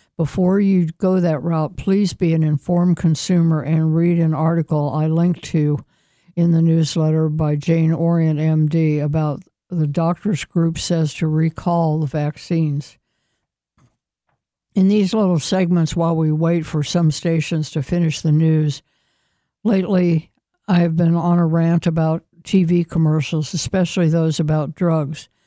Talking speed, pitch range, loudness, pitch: 145 wpm, 155-175 Hz, -18 LUFS, 165 Hz